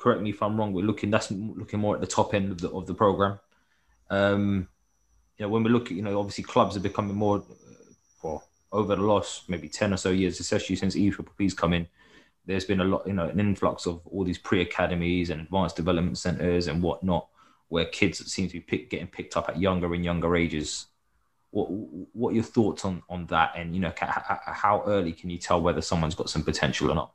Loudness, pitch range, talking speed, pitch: -27 LUFS, 85-100 Hz, 235 wpm, 95 Hz